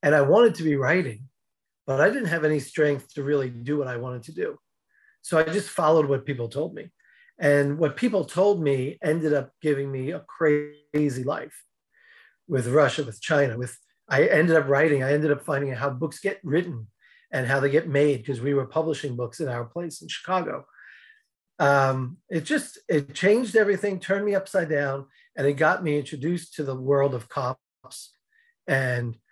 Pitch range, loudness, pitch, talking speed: 140-175 Hz, -24 LUFS, 150 Hz, 190 wpm